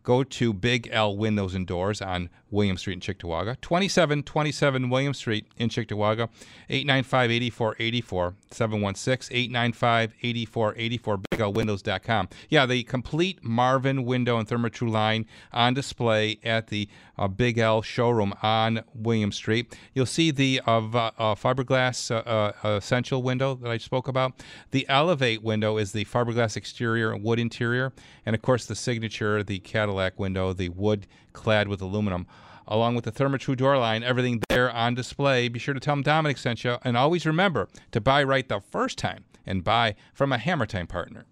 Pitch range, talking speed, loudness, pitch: 105-130 Hz, 160 wpm, -25 LUFS, 115 Hz